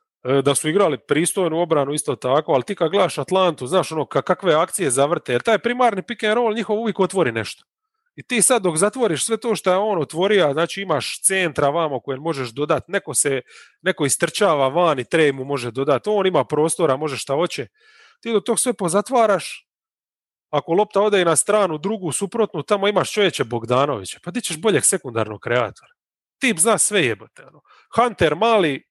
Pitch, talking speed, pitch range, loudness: 185 Hz, 190 wpm, 150-215 Hz, -19 LUFS